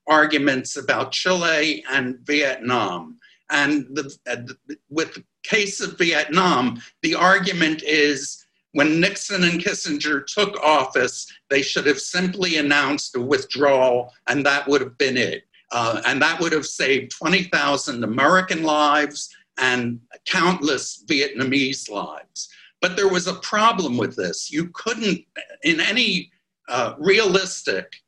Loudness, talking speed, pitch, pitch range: -20 LUFS, 135 wpm, 150 Hz, 140-185 Hz